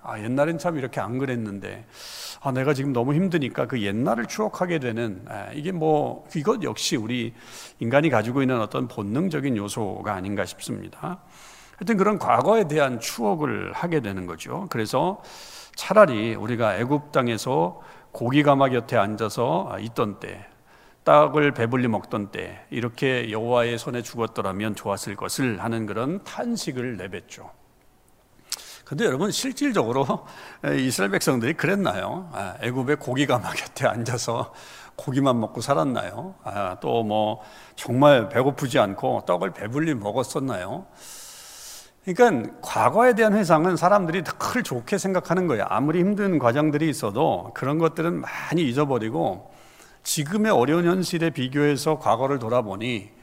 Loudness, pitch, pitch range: -24 LUFS, 130 Hz, 115-160 Hz